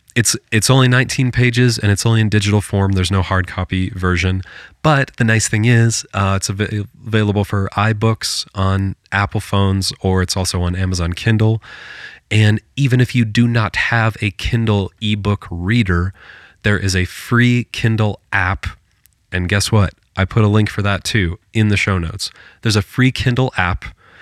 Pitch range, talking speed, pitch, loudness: 95-115 Hz, 180 wpm, 105 Hz, -16 LUFS